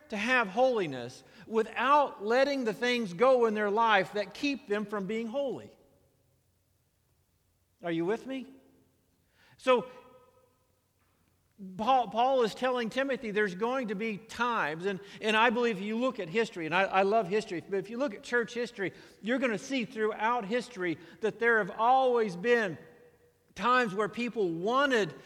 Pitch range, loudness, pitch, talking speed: 185-245 Hz, -29 LUFS, 220 Hz, 160 wpm